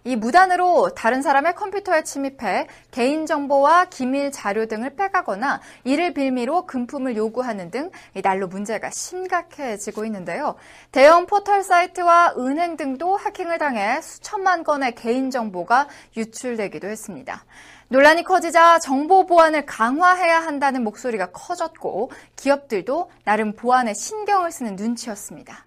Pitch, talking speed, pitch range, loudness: 280 Hz, 325 characters per minute, 235-345 Hz, -20 LUFS